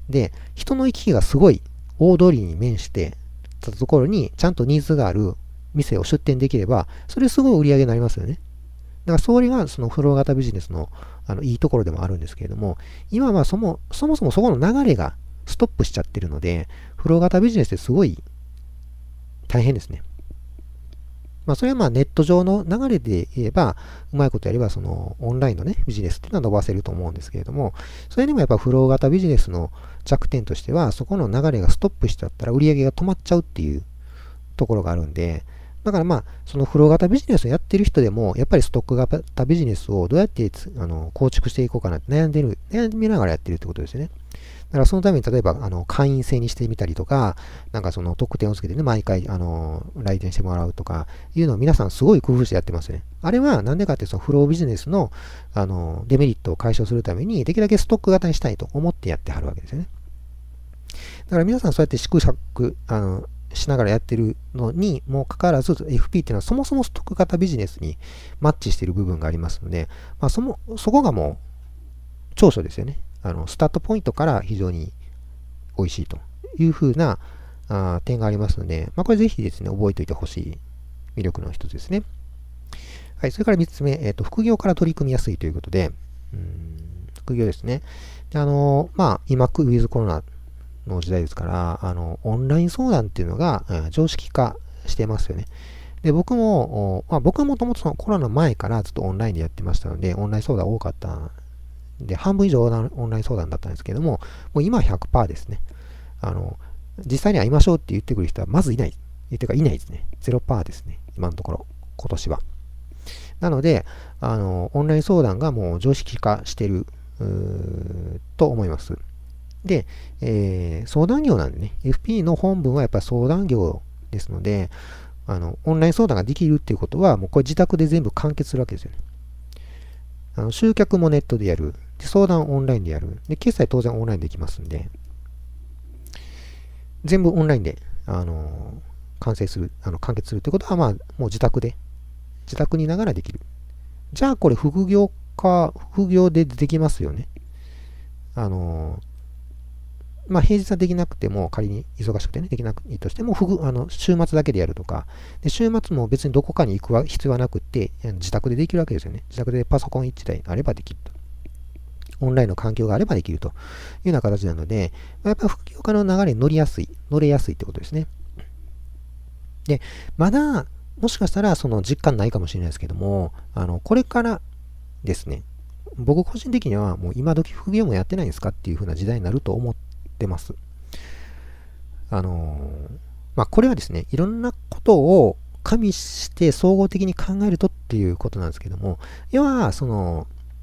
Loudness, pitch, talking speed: -21 LUFS, 100 Hz, 395 characters per minute